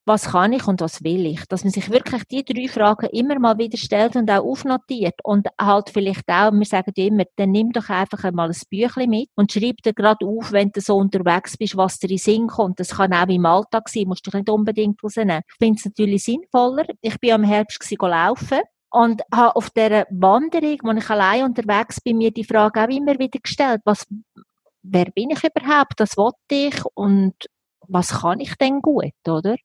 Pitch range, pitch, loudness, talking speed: 195-235 Hz, 215 Hz, -19 LUFS, 220 wpm